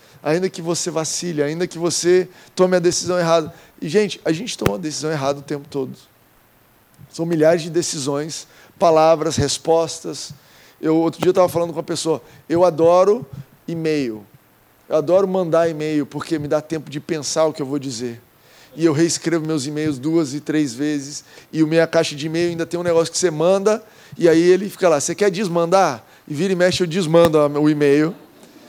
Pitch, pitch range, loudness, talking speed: 160 Hz, 150-175 Hz, -19 LUFS, 195 wpm